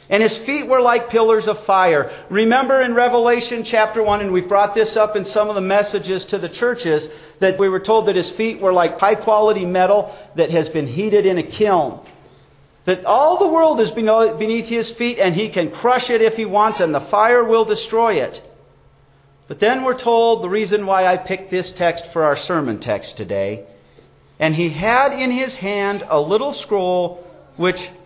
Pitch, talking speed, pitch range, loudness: 210 Hz, 200 wpm, 185-230 Hz, -17 LUFS